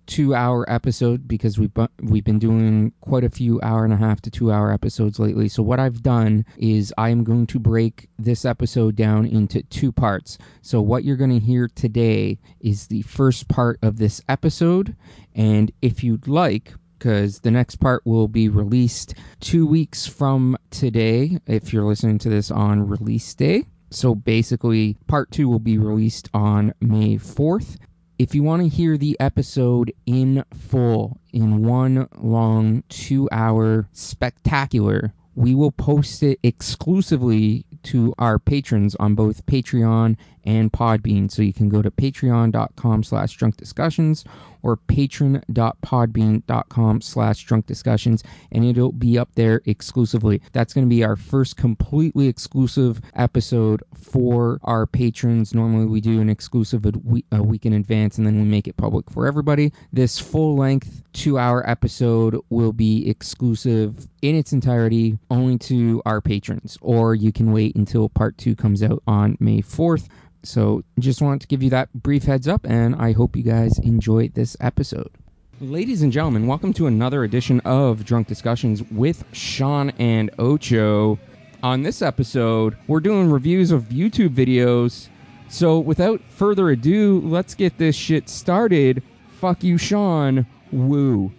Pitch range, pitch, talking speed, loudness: 110-135 Hz, 120 Hz, 160 wpm, -19 LUFS